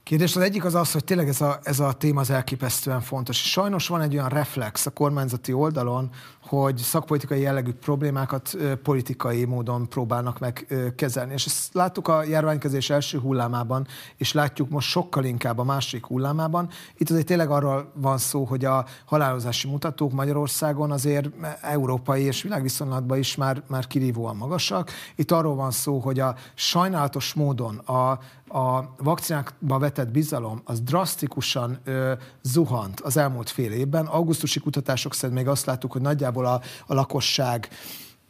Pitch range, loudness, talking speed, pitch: 130-150 Hz, -25 LUFS, 155 wpm, 135 Hz